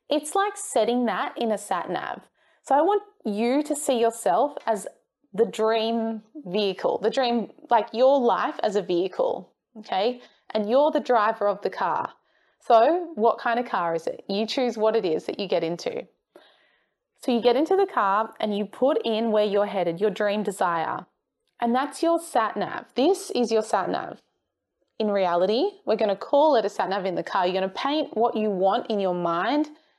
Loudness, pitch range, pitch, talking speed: -24 LUFS, 210-280 Hz, 230 Hz, 195 wpm